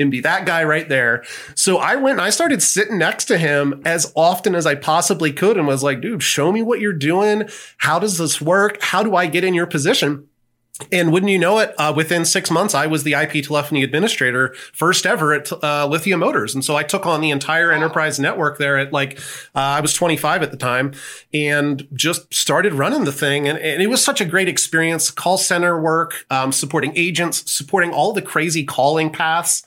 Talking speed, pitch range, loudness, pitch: 220 wpm, 145-180 Hz, -17 LUFS, 160 Hz